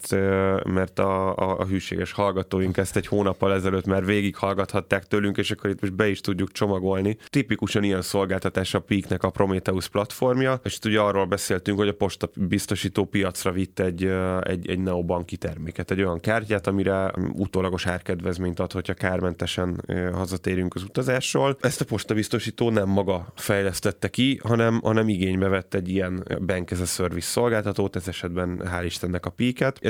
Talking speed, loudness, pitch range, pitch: 160 wpm, -25 LUFS, 95-105 Hz, 95 Hz